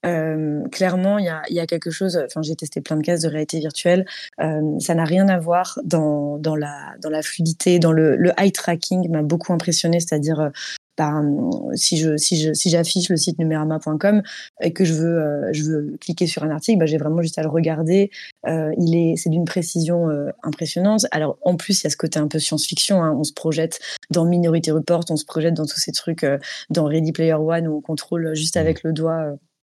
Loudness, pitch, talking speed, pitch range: -20 LUFS, 165 Hz, 230 wpm, 155-175 Hz